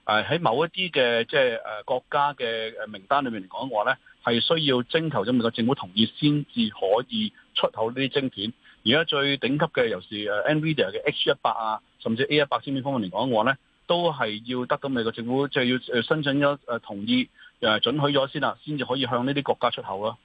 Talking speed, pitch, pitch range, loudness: 340 characters per minute, 140 Hz, 120-155 Hz, -25 LUFS